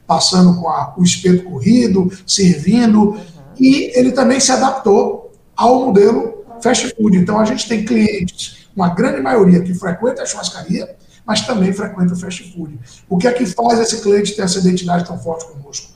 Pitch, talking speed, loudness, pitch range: 200 Hz, 180 wpm, -14 LUFS, 180-235 Hz